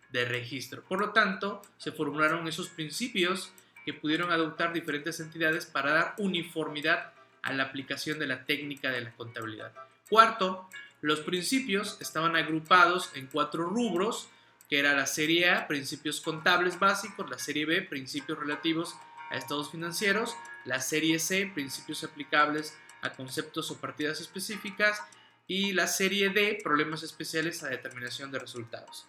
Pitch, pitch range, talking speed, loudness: 160 Hz, 145-185 Hz, 145 wpm, -29 LUFS